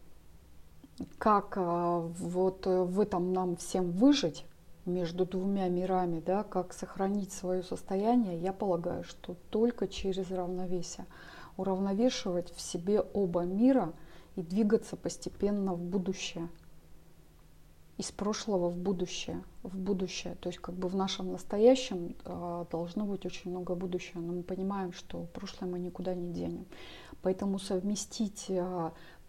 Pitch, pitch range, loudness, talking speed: 185 Hz, 175-195 Hz, -33 LUFS, 125 wpm